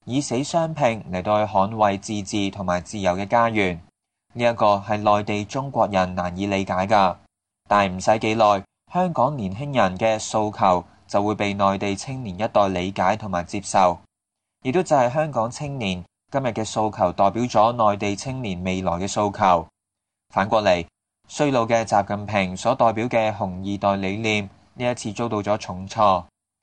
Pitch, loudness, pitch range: 105 Hz, -22 LUFS, 100-115 Hz